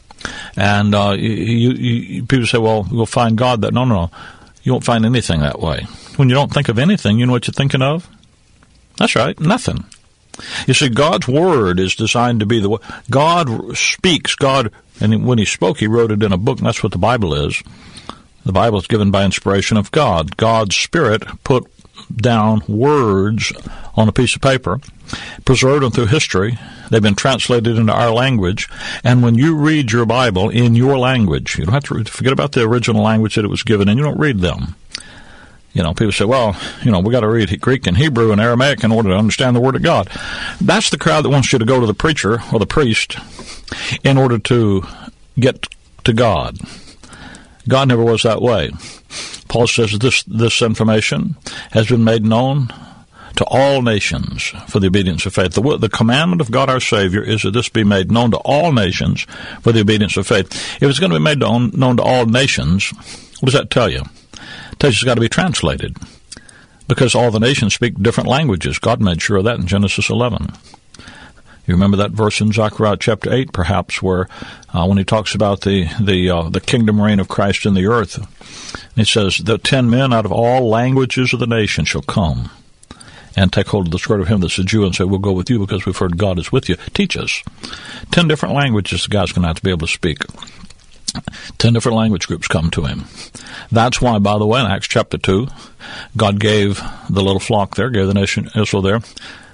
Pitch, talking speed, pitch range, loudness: 110 Hz, 210 wpm, 100-125 Hz, -15 LUFS